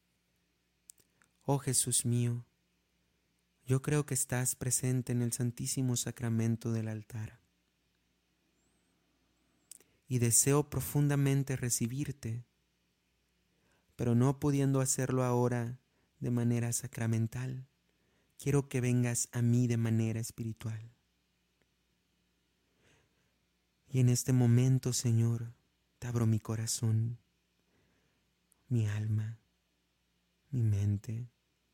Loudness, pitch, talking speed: -32 LUFS, 115 Hz, 90 wpm